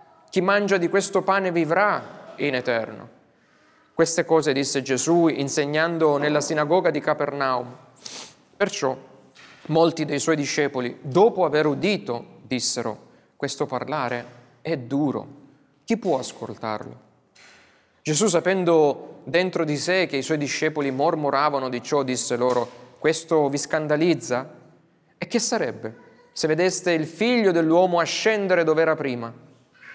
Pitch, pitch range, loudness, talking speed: 155 Hz, 140-175 Hz, -22 LUFS, 125 wpm